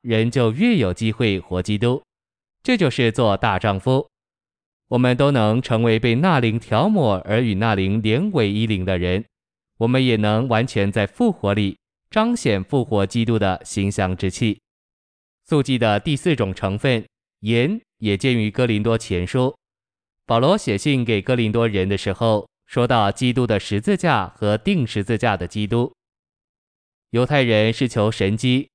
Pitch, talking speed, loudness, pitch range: 115 Hz, 230 characters per minute, -20 LUFS, 100-125 Hz